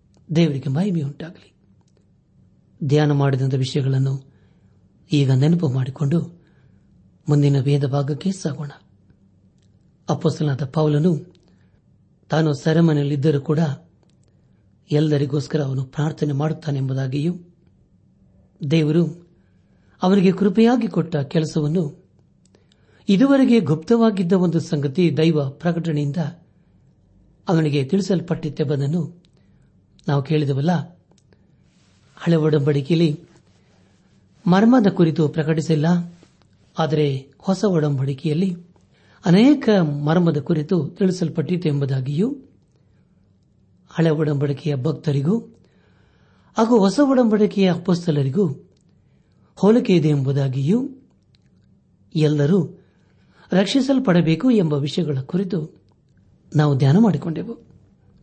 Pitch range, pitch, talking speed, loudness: 145-180 Hz, 160 Hz, 70 wpm, -20 LUFS